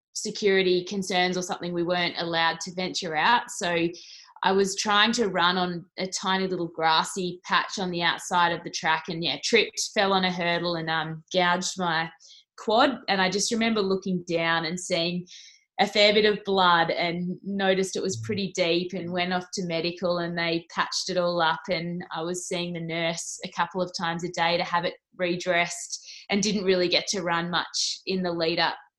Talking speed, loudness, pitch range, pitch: 200 wpm, -25 LUFS, 170-190 Hz, 180 Hz